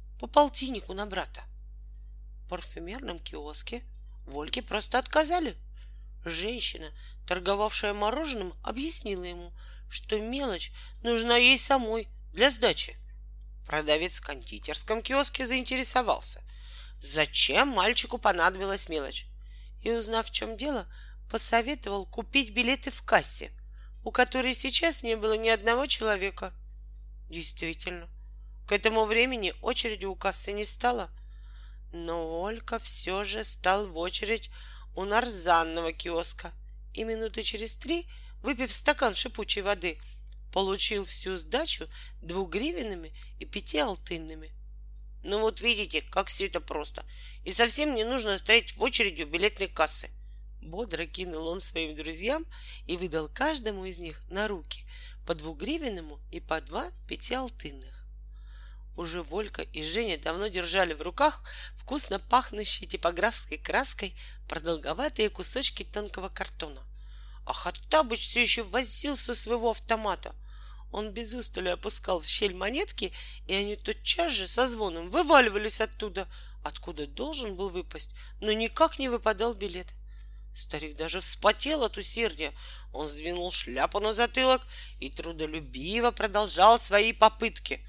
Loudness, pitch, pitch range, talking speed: -28 LUFS, 205 Hz, 165-235 Hz, 125 wpm